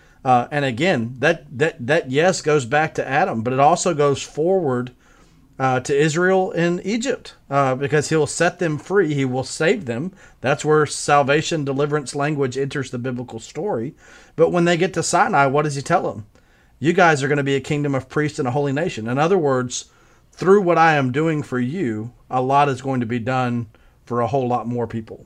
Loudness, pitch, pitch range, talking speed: -20 LUFS, 145 Hz, 130-160 Hz, 210 wpm